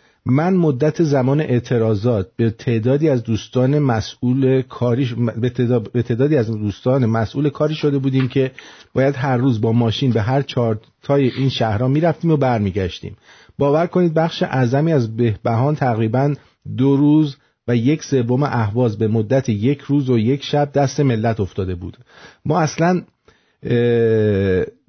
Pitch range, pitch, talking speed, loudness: 115-145 Hz, 130 Hz, 150 wpm, -18 LUFS